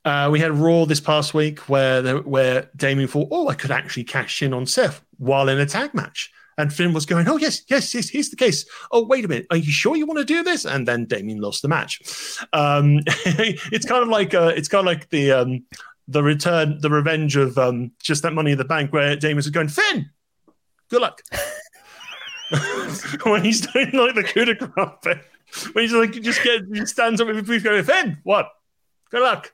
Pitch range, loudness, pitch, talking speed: 145-225 Hz, -20 LUFS, 160 Hz, 215 wpm